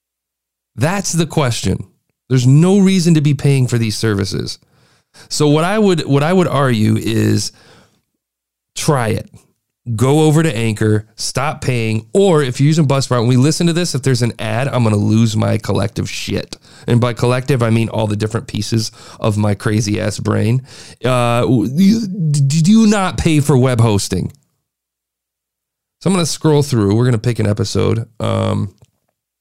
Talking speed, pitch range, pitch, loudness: 175 wpm, 110-150 Hz, 120 Hz, -15 LUFS